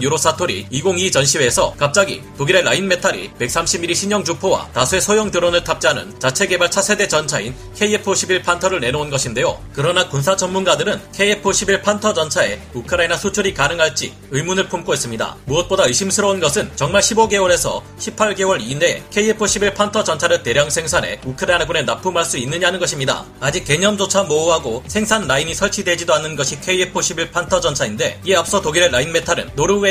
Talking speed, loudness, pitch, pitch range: 405 characters per minute, -16 LUFS, 180 Hz, 155-200 Hz